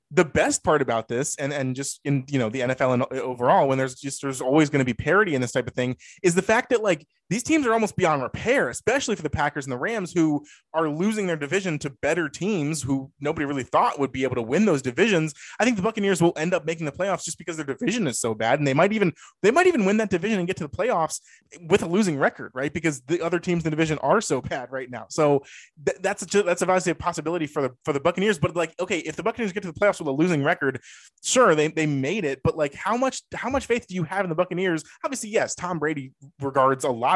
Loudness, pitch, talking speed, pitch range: -24 LUFS, 160 Hz, 270 wpm, 140-185 Hz